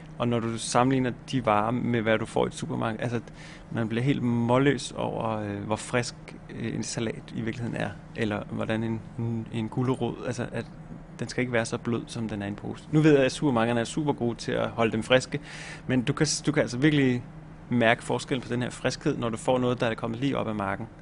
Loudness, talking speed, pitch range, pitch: -27 LUFS, 235 wpm, 115-145 Hz, 120 Hz